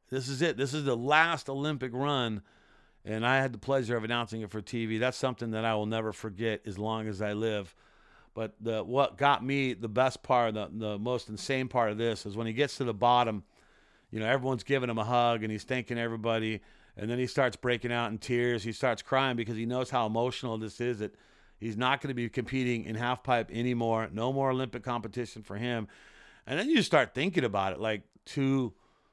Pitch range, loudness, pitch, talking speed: 110-130 Hz, -31 LUFS, 120 Hz, 220 wpm